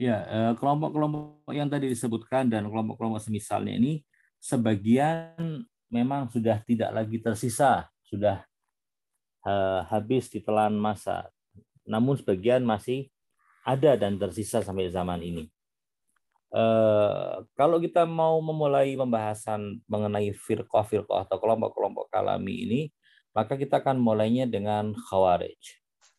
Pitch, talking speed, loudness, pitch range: 115 Hz, 105 wpm, -27 LUFS, 105-135 Hz